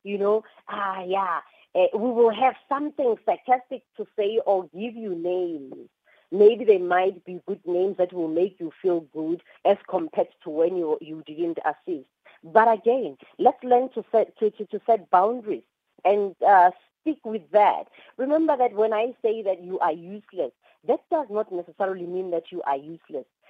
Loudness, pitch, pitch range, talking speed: -24 LUFS, 205 Hz, 180-235 Hz, 175 wpm